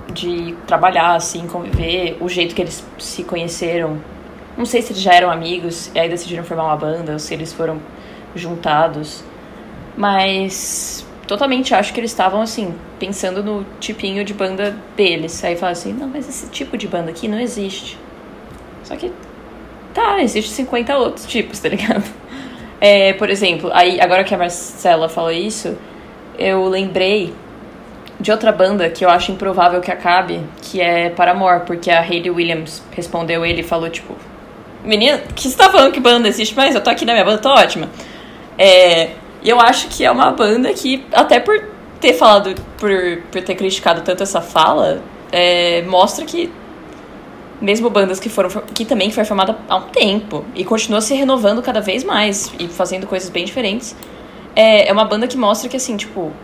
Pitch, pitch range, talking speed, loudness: 190 Hz, 175-220 Hz, 180 wpm, -15 LUFS